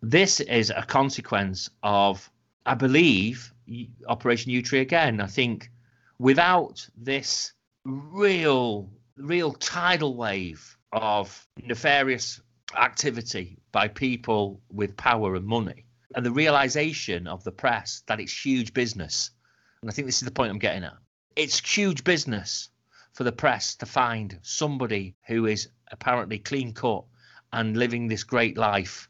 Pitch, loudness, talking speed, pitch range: 120 Hz, -25 LUFS, 140 wpm, 110-135 Hz